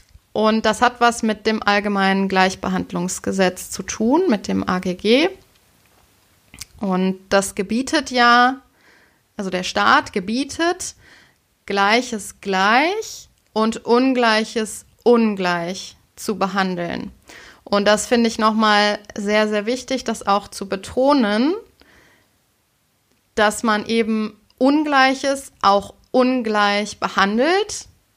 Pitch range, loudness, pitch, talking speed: 195-245 Hz, -19 LUFS, 215 Hz, 100 wpm